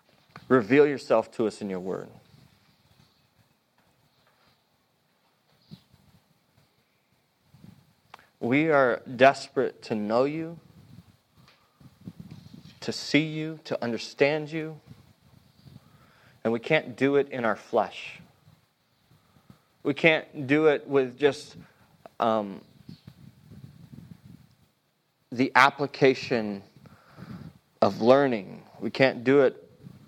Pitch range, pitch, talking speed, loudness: 120-145 Hz, 135 Hz, 85 wpm, -25 LUFS